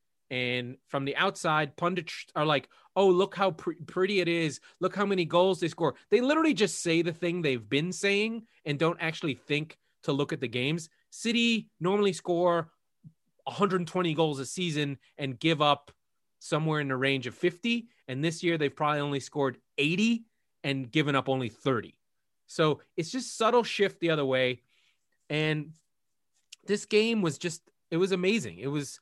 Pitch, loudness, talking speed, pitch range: 165 Hz, -29 LUFS, 175 wpm, 145-190 Hz